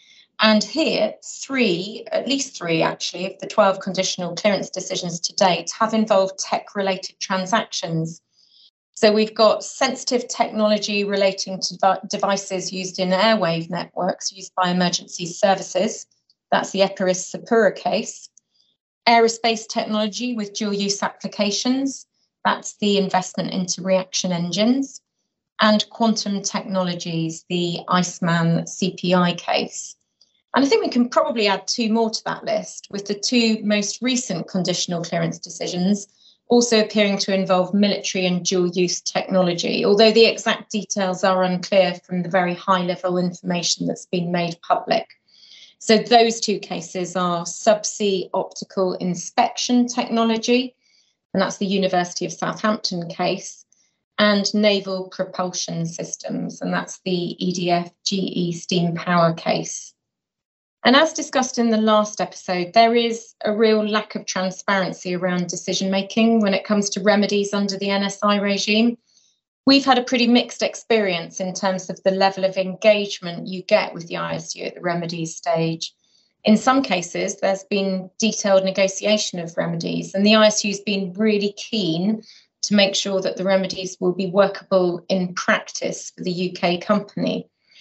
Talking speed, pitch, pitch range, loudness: 145 wpm, 195 Hz, 185-215 Hz, -21 LUFS